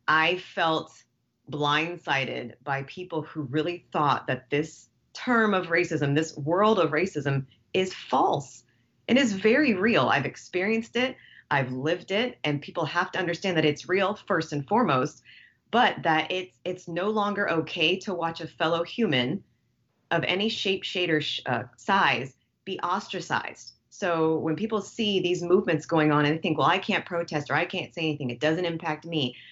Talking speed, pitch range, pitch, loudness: 175 wpm, 150-190 Hz, 170 Hz, -26 LUFS